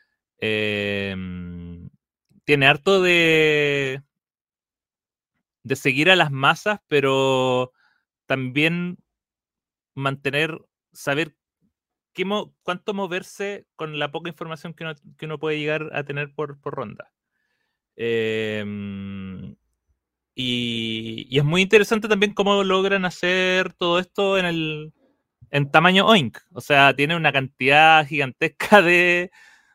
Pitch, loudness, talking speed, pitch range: 155 Hz, -20 LUFS, 115 wpm, 130-180 Hz